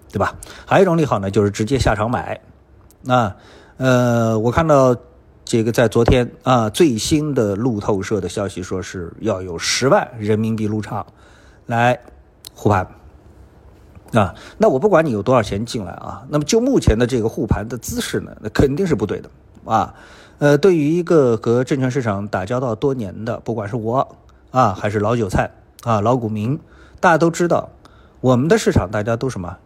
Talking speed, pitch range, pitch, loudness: 265 characters per minute, 105-130 Hz, 115 Hz, -18 LUFS